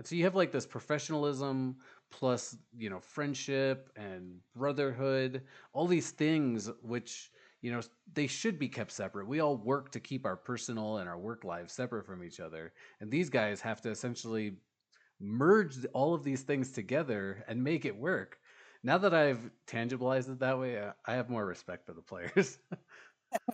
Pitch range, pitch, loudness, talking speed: 110-140 Hz, 125 Hz, -34 LUFS, 175 wpm